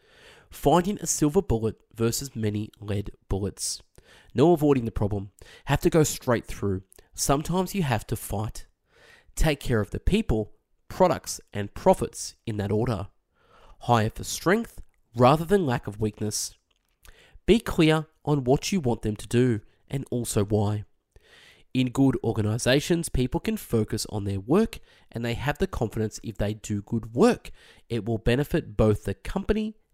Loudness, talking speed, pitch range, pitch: -26 LUFS, 155 wpm, 105-150 Hz, 115 Hz